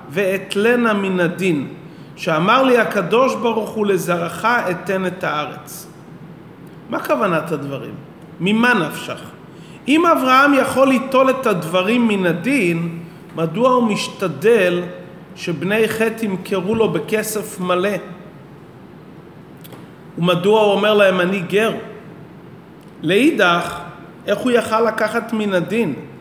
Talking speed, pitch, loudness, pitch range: 110 wpm, 195 Hz, -17 LUFS, 175-220 Hz